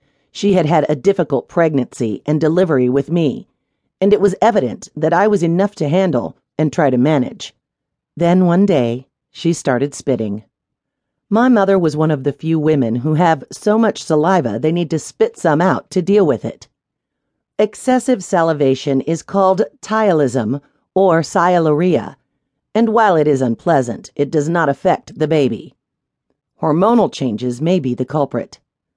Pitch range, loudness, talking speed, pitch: 140-190 Hz, -16 LUFS, 160 wpm, 155 Hz